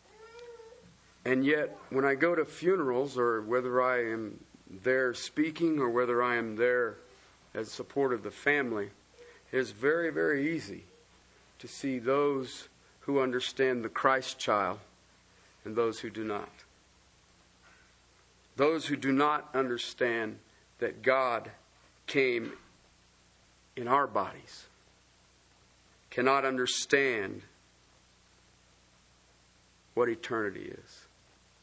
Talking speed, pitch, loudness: 110 wpm, 125 Hz, -30 LUFS